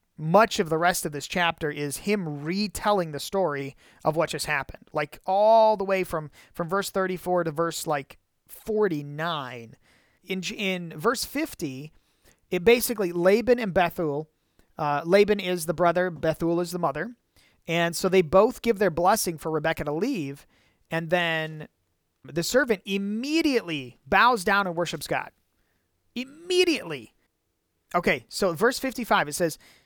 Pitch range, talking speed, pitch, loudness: 155-205 Hz, 150 wpm, 175 Hz, -25 LUFS